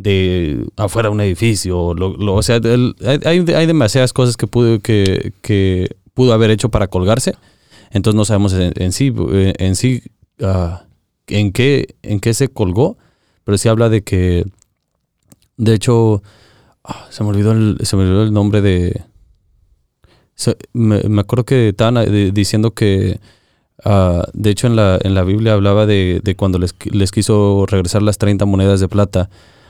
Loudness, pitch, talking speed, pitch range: -14 LUFS, 105 Hz, 170 wpm, 95-115 Hz